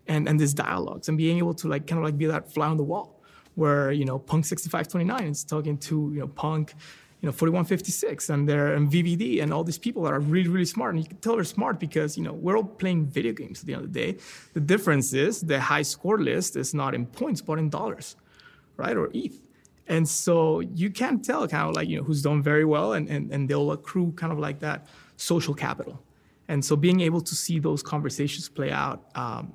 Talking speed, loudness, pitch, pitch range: 240 wpm, -26 LUFS, 155 Hz, 150-175 Hz